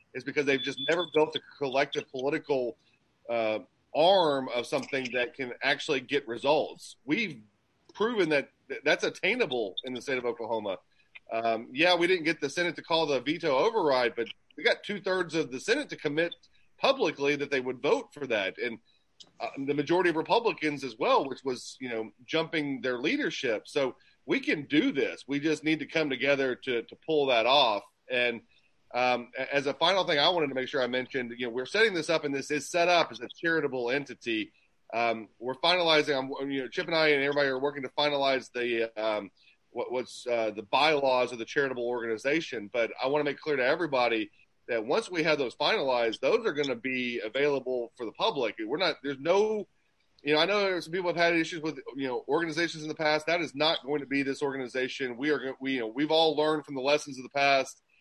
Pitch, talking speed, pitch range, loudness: 140 Hz, 215 wpm, 130-160 Hz, -29 LUFS